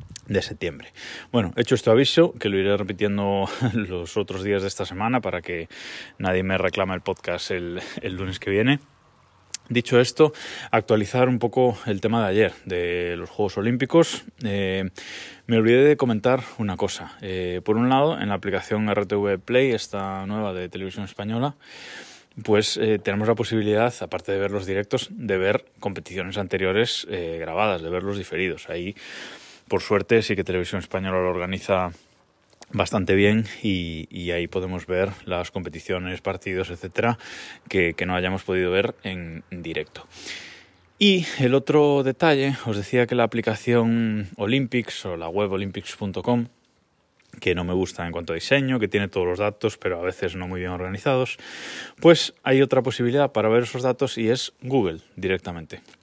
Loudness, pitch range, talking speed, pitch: -23 LUFS, 95-120 Hz, 165 wpm, 100 Hz